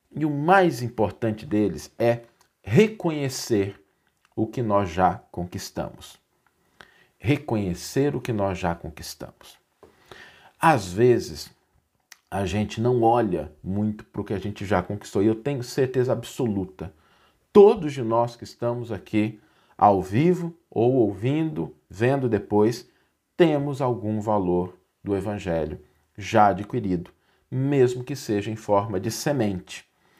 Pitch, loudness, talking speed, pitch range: 110 Hz, -24 LUFS, 125 wpm, 100-125 Hz